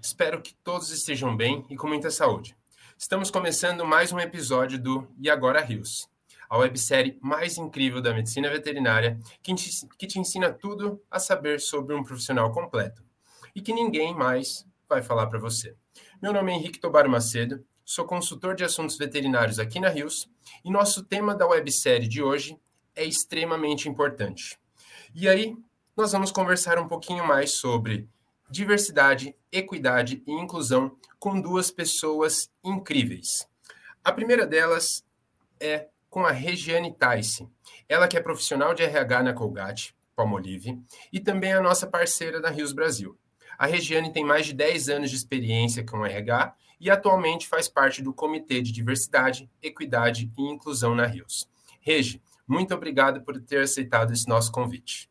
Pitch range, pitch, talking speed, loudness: 125-175 Hz, 145 Hz, 160 wpm, -25 LUFS